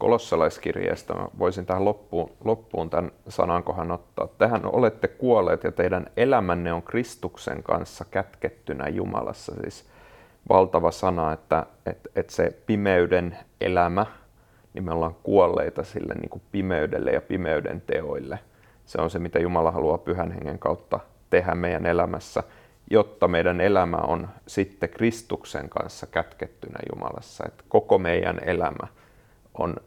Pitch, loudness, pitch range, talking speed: 90 Hz, -25 LUFS, 85-110 Hz, 130 wpm